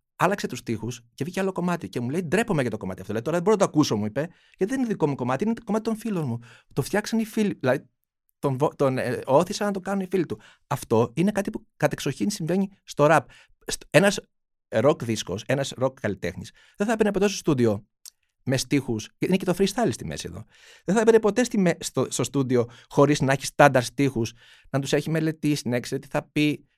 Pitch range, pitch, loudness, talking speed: 125-195 Hz, 150 Hz, -25 LUFS, 230 wpm